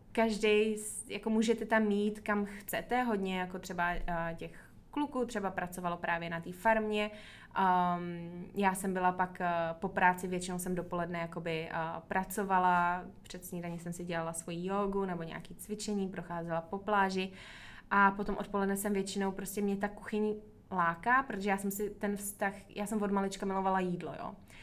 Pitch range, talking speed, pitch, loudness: 175-205 Hz, 170 wpm, 195 Hz, -34 LUFS